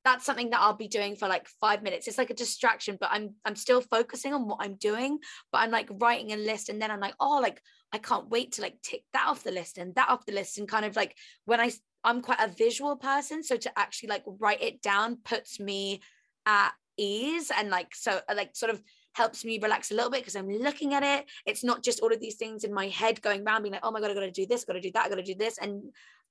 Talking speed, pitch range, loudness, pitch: 270 wpm, 205-245 Hz, -29 LUFS, 220 Hz